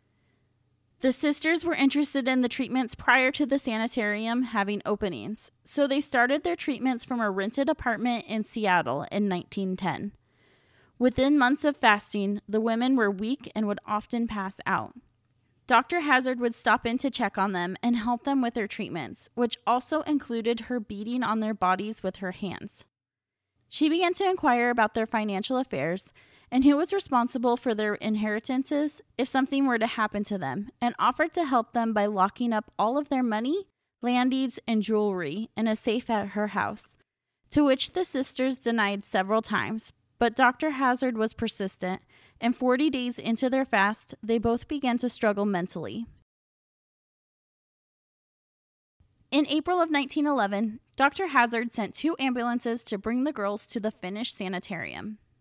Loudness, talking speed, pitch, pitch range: -27 LUFS, 165 wpm, 235 Hz, 210-260 Hz